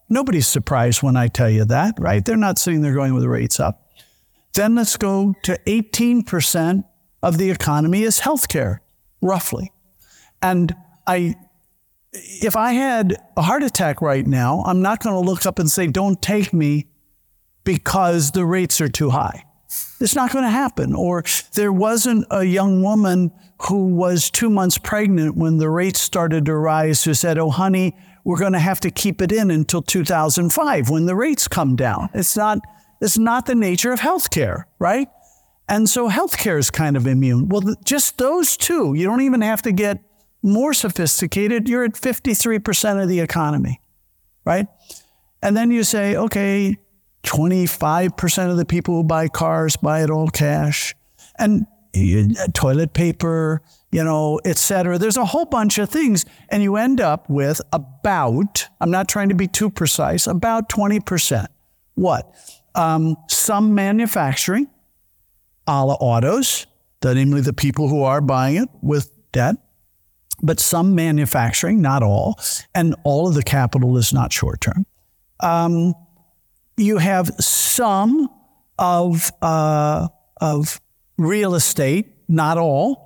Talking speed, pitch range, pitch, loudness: 160 wpm, 150-205 Hz, 175 Hz, -18 LUFS